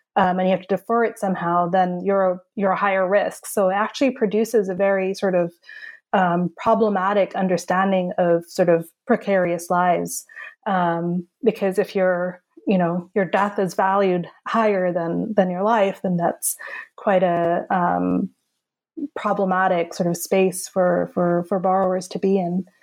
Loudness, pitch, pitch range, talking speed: -21 LUFS, 190 Hz, 180-205 Hz, 165 wpm